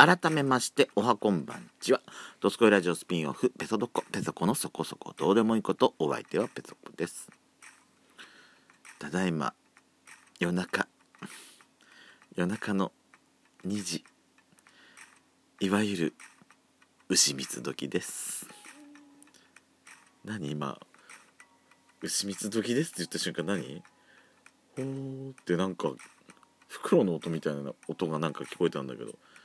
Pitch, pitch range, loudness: 100 Hz, 85-135 Hz, -30 LUFS